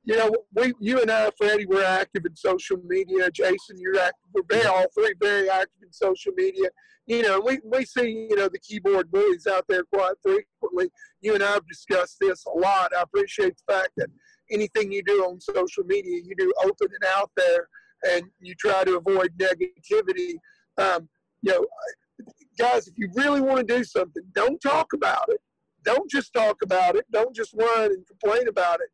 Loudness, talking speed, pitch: -24 LUFS, 195 wpm, 225 Hz